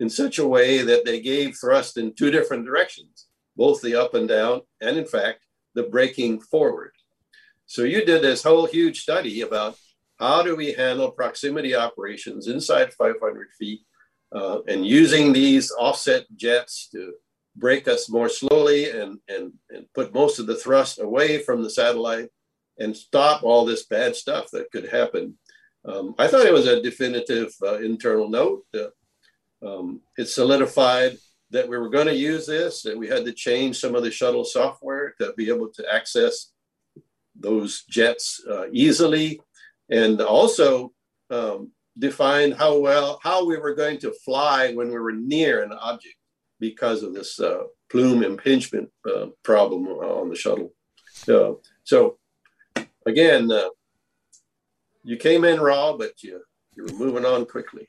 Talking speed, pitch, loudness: 160 wpm, 150 Hz, -21 LUFS